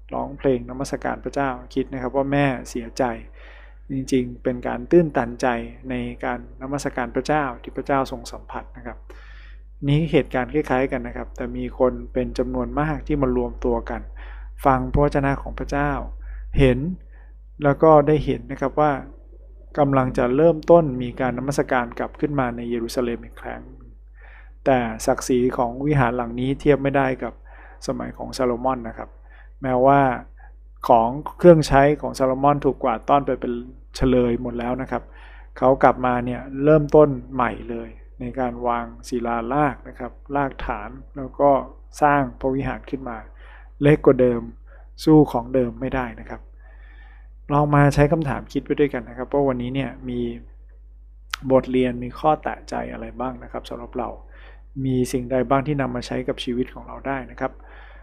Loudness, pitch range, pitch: -22 LUFS, 120-140 Hz, 130 Hz